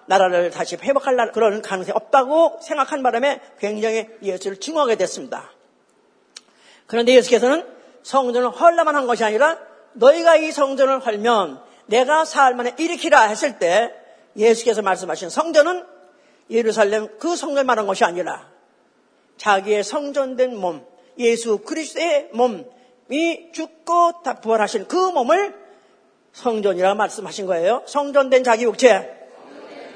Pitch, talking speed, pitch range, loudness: 250 Hz, 300 characters per minute, 220-295 Hz, -19 LUFS